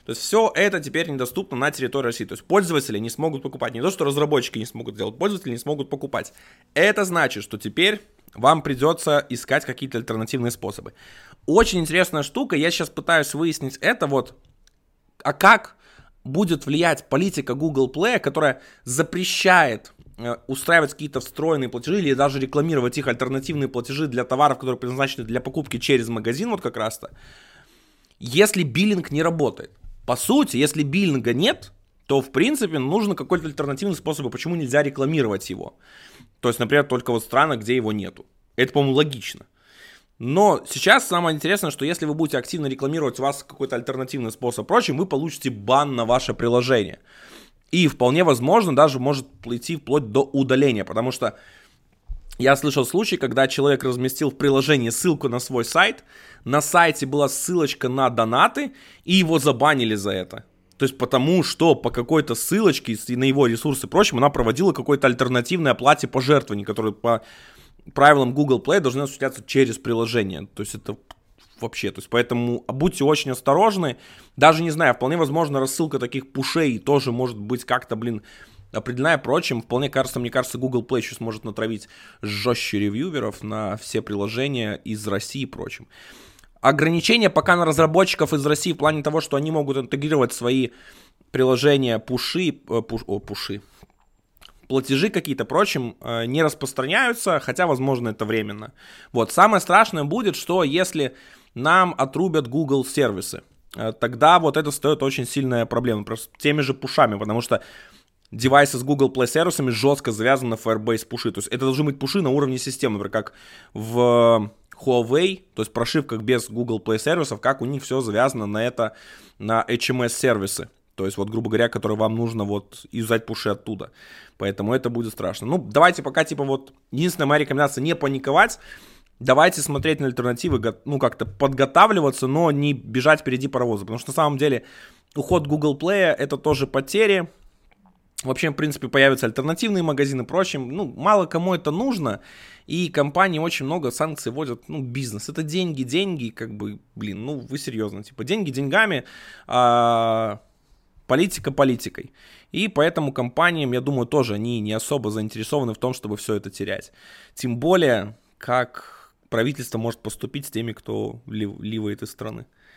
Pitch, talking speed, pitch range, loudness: 135 Hz, 160 wpm, 115-150 Hz, -21 LUFS